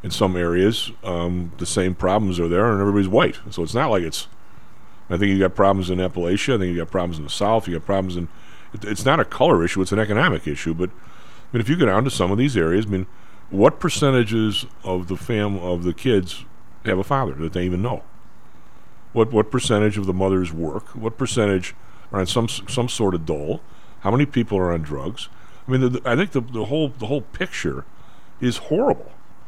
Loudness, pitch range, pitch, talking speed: -21 LUFS, 90-120 Hz, 100 Hz, 225 wpm